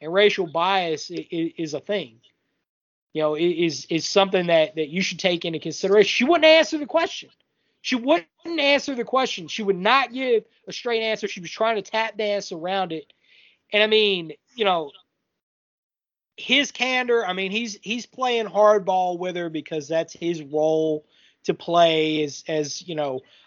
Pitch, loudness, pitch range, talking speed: 190 Hz, -22 LUFS, 165-225 Hz, 175 wpm